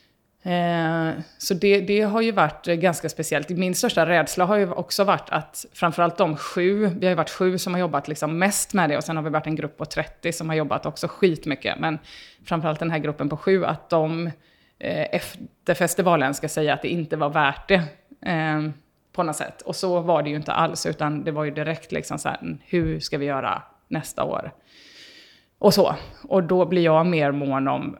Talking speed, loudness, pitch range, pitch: 210 wpm, -23 LUFS, 155-185 Hz, 165 Hz